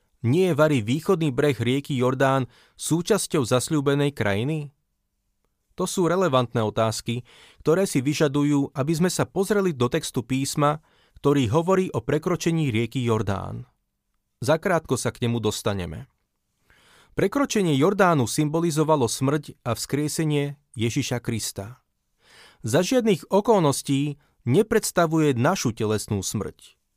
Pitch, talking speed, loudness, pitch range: 145 Hz, 110 wpm, -23 LUFS, 120-165 Hz